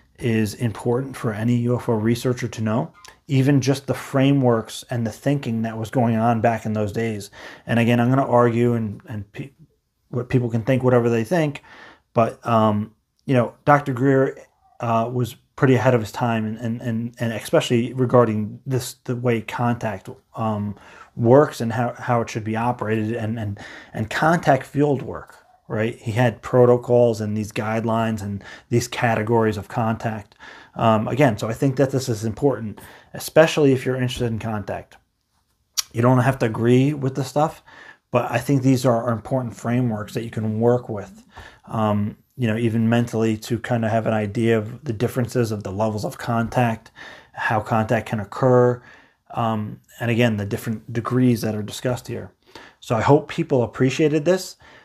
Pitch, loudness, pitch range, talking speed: 120 Hz, -21 LUFS, 110-130 Hz, 180 wpm